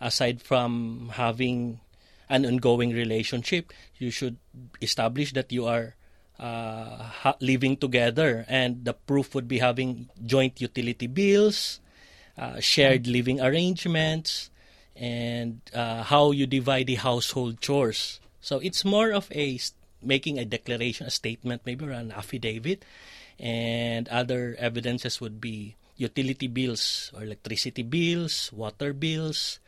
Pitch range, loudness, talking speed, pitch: 115-135 Hz, -27 LUFS, 130 wpm, 125 Hz